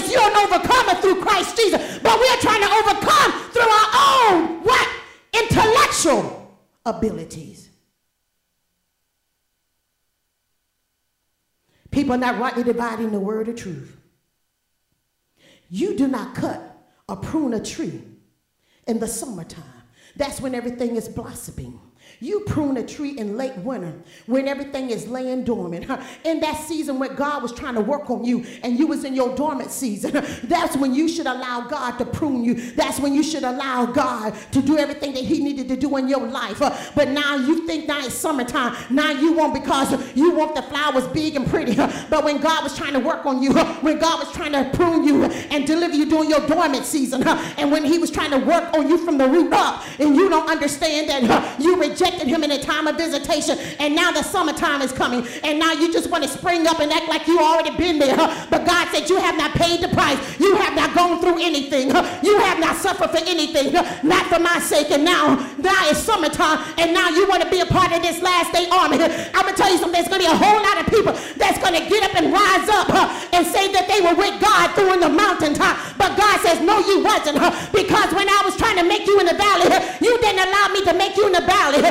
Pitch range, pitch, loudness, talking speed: 265-350 Hz, 310 Hz, -18 LUFS, 210 wpm